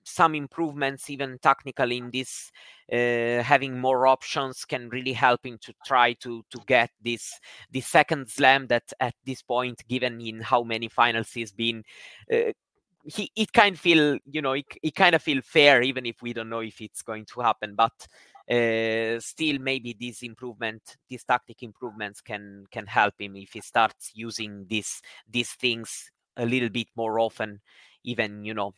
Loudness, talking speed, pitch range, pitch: -25 LUFS, 180 wpm, 115-135 Hz, 120 Hz